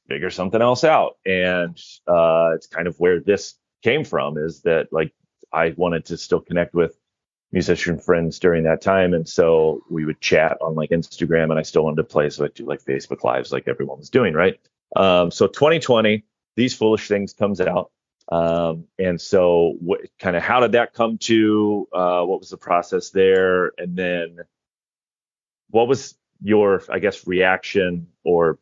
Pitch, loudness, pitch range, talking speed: 90 Hz, -20 LUFS, 85-100 Hz, 180 wpm